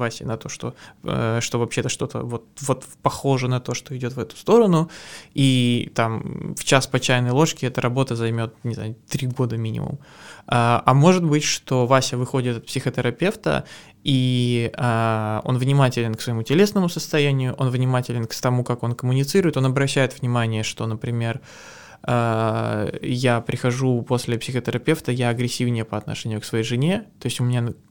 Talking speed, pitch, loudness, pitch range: 160 wpm, 125 Hz, -22 LUFS, 115-135 Hz